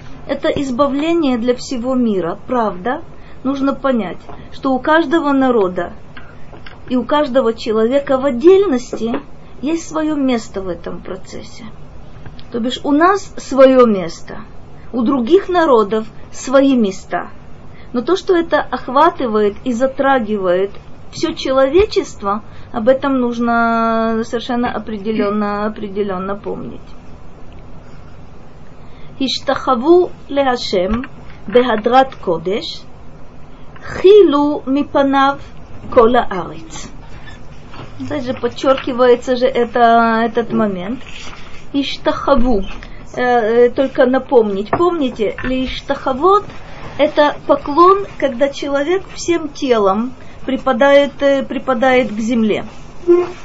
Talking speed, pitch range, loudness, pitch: 90 wpm, 235-285 Hz, -15 LUFS, 265 Hz